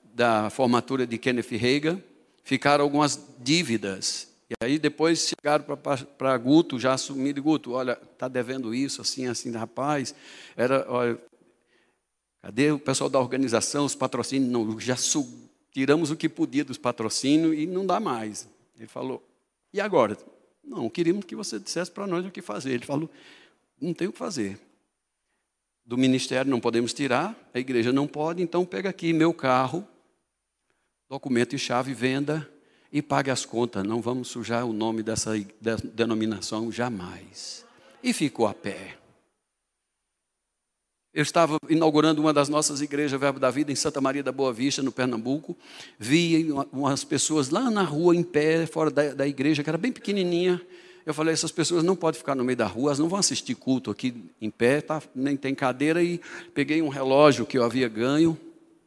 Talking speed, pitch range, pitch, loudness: 165 wpm, 125-160 Hz, 140 Hz, -26 LUFS